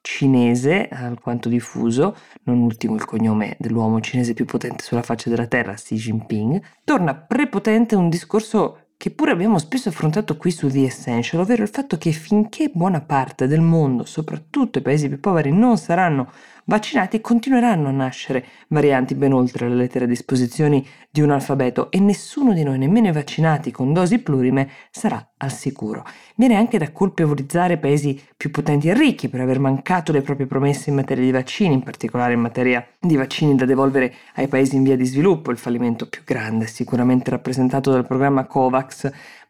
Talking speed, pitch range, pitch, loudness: 175 wpm, 125-180 Hz, 140 Hz, -19 LUFS